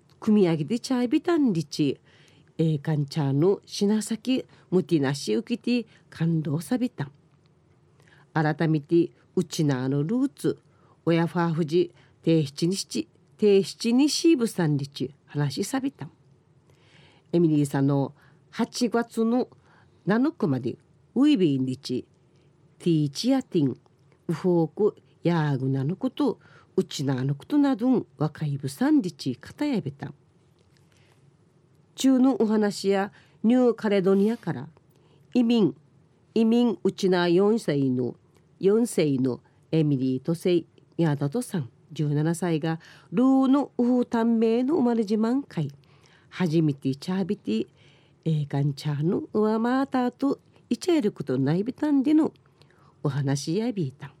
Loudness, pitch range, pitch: -25 LUFS, 145-225 Hz, 165 Hz